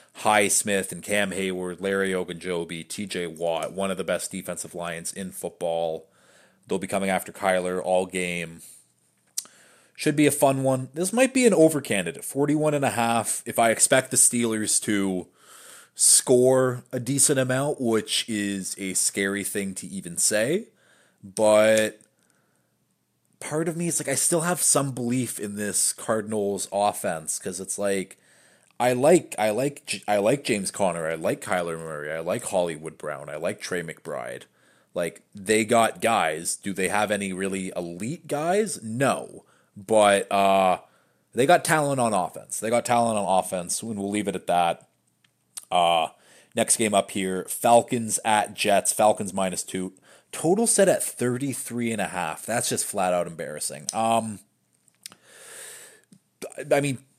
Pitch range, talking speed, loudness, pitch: 95-130 Hz, 160 wpm, -24 LUFS, 105 Hz